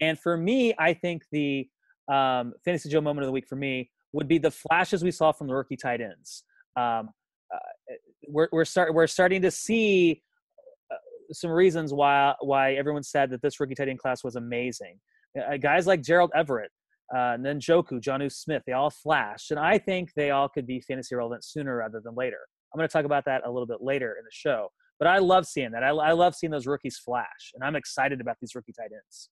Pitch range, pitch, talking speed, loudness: 130-175 Hz, 145 Hz, 220 wpm, -26 LUFS